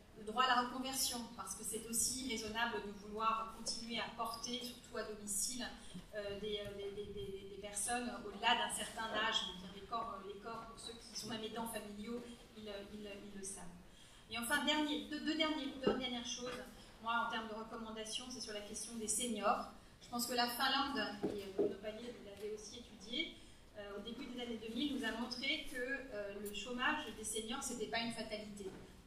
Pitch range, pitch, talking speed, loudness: 210-245 Hz, 225 Hz, 200 wpm, -41 LUFS